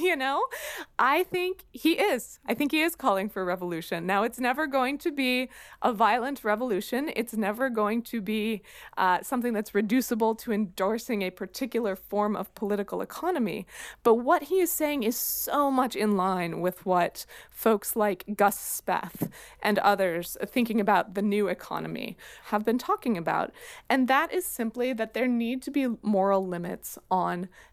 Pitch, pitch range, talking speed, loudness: 225 Hz, 200-260 Hz, 170 wpm, -27 LUFS